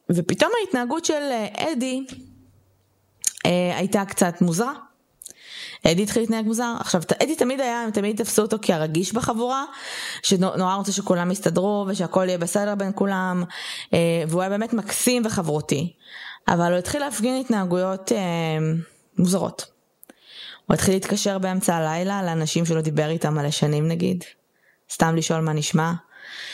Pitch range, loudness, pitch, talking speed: 170-225 Hz, -23 LUFS, 190 Hz, 140 wpm